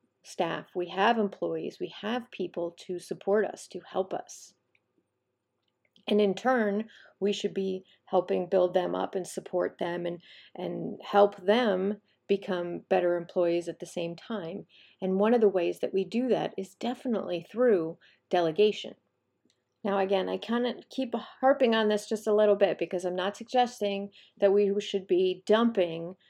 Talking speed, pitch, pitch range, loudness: 165 wpm, 195 Hz, 180-215 Hz, -29 LUFS